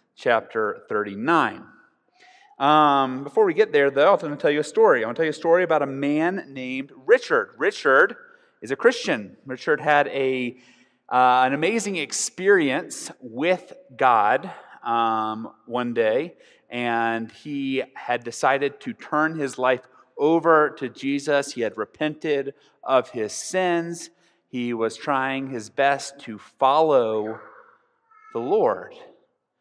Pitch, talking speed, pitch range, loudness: 145 Hz, 140 wpm, 130-210 Hz, -22 LUFS